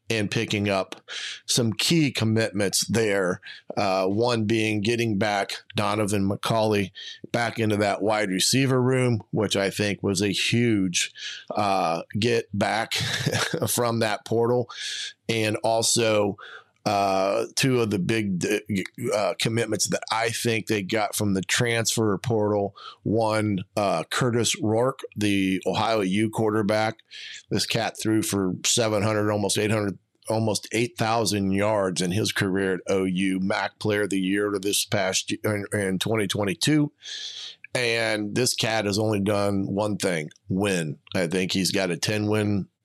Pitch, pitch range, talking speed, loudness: 105 Hz, 100-115 Hz, 140 wpm, -24 LUFS